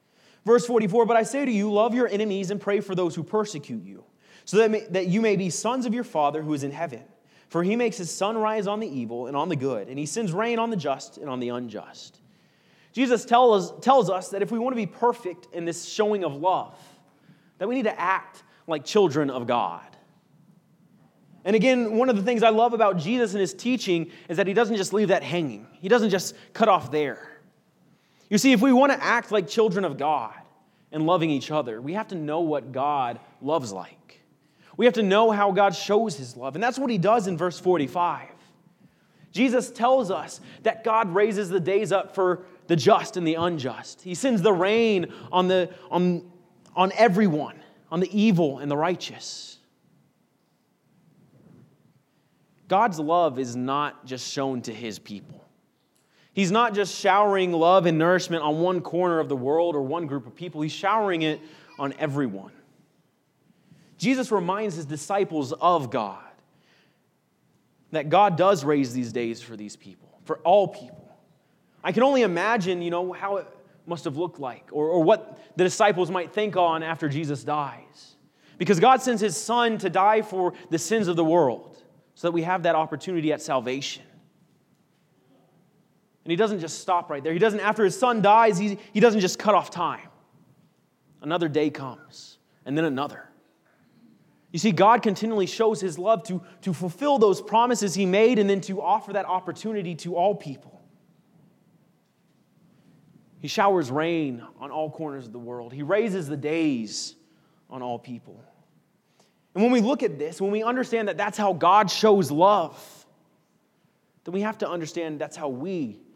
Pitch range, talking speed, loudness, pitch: 155-210 Hz, 185 wpm, -24 LUFS, 180 Hz